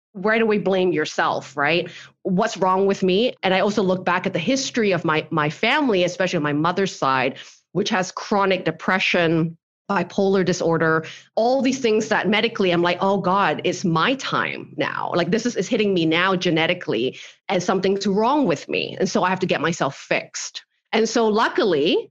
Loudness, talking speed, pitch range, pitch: -21 LUFS, 185 wpm, 170-215 Hz, 185 Hz